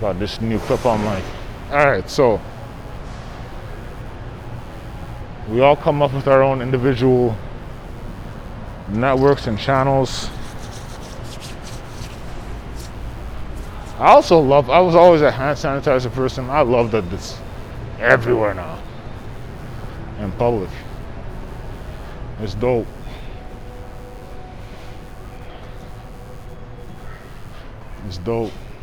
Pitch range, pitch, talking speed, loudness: 110-130 Hz, 125 Hz, 85 wpm, -17 LUFS